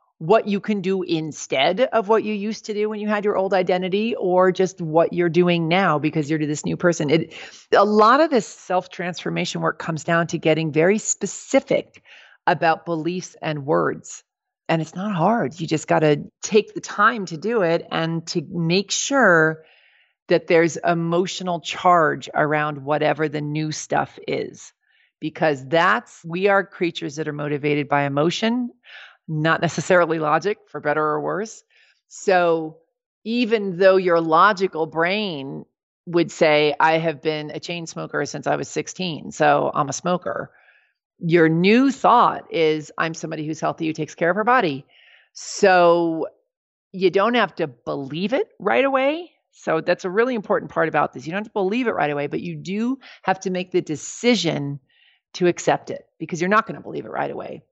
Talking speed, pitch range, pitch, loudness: 180 wpm, 160-200 Hz, 175 Hz, -21 LUFS